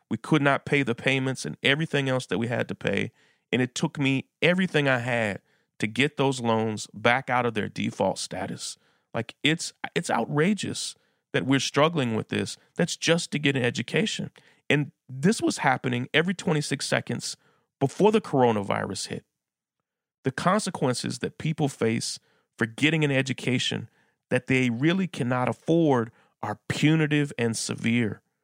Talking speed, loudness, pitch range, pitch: 160 wpm, -26 LUFS, 125-155 Hz, 140 Hz